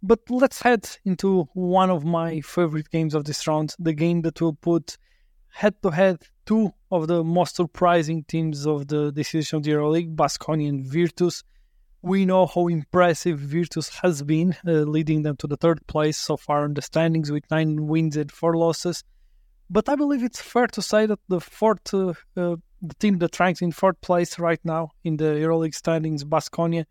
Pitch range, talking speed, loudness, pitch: 155-180 Hz, 190 wpm, -23 LUFS, 165 Hz